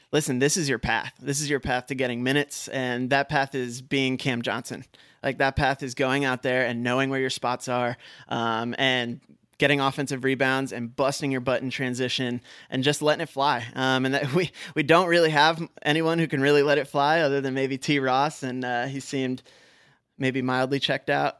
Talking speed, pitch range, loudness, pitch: 215 wpm, 130-145 Hz, -25 LUFS, 135 Hz